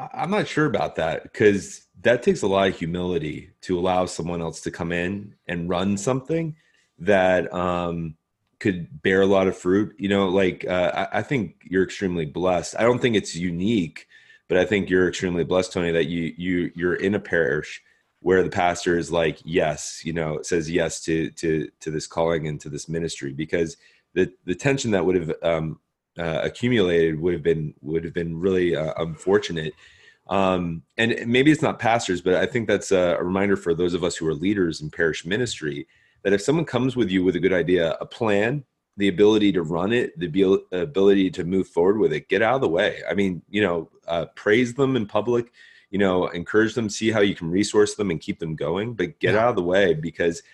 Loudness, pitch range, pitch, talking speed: -23 LUFS, 85-100 Hz, 95 Hz, 215 wpm